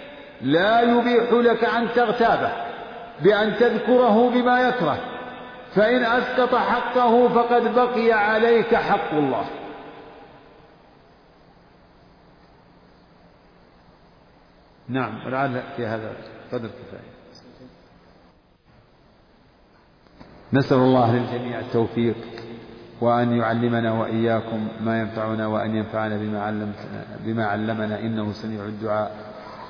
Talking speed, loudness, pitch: 80 wpm, -21 LUFS, 120 Hz